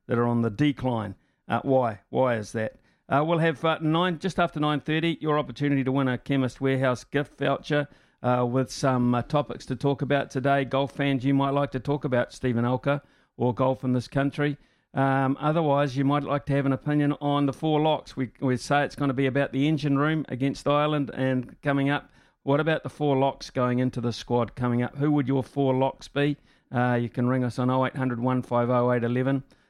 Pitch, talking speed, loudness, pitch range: 135 Hz, 225 wpm, -26 LUFS, 125-145 Hz